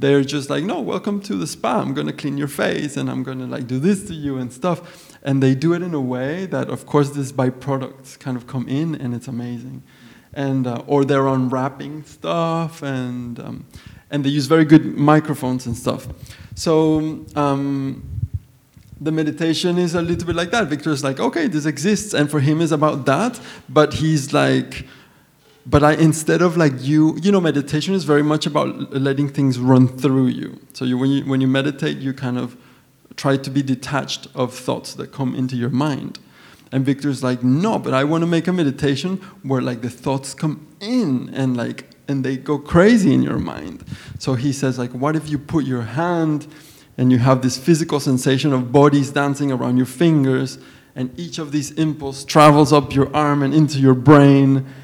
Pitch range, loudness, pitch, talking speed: 130-155 Hz, -19 LUFS, 140 Hz, 200 wpm